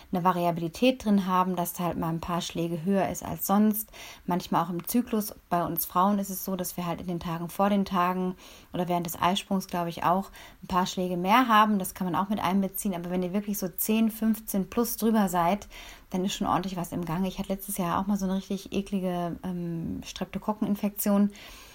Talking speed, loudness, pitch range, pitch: 225 wpm, -28 LUFS, 175-205 Hz, 185 Hz